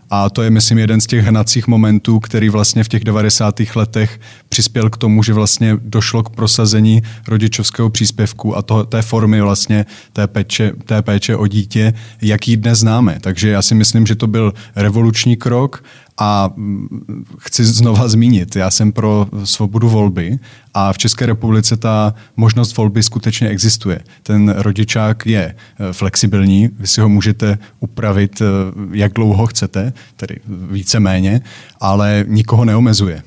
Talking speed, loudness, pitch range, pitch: 150 wpm, -13 LUFS, 105-115 Hz, 110 Hz